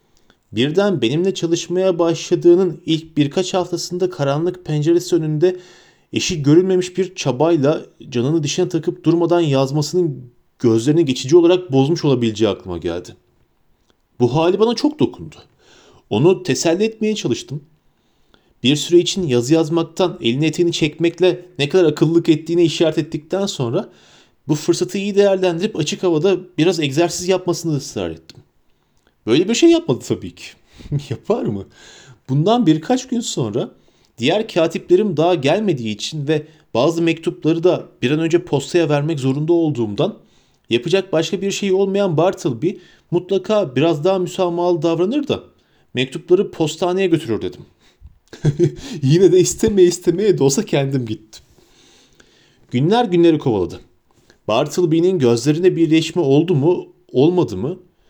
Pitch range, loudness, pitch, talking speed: 150-180 Hz, -17 LUFS, 170 Hz, 130 wpm